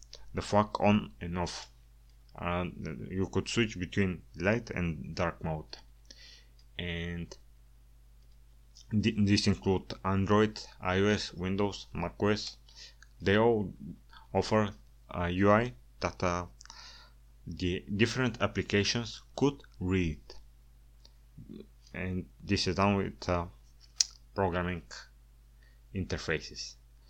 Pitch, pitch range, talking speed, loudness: 90 Hz, 60-100 Hz, 95 wpm, -32 LUFS